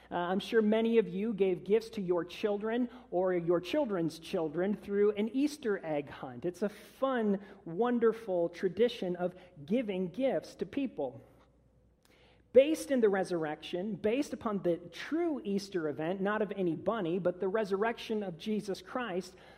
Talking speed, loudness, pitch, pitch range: 155 wpm, -33 LUFS, 200 Hz, 180-225 Hz